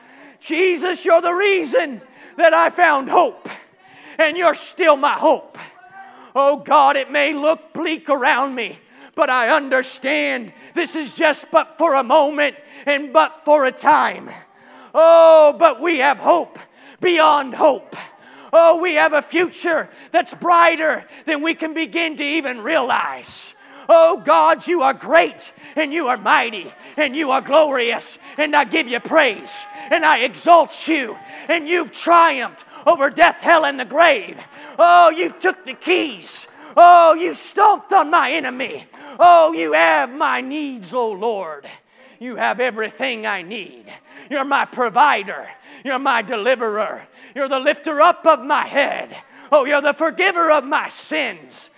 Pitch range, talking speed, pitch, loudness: 275-330 Hz, 150 wpm, 310 Hz, -16 LUFS